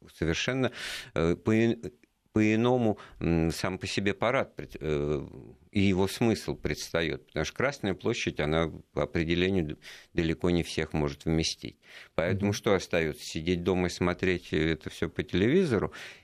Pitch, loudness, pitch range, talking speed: 90 Hz, -29 LUFS, 80-100 Hz, 125 wpm